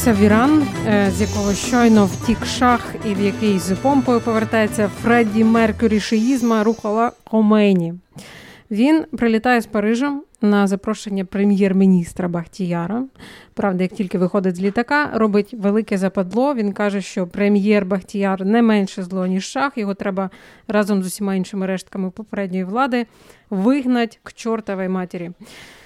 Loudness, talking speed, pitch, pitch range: -18 LUFS, 130 wpm, 210 Hz, 195-230 Hz